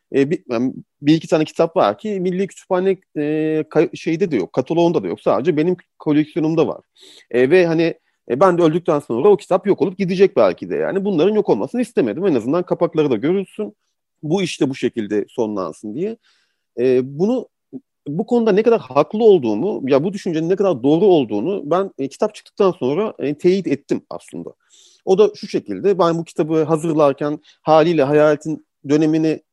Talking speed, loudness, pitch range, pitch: 180 wpm, -18 LUFS, 150-195 Hz, 165 Hz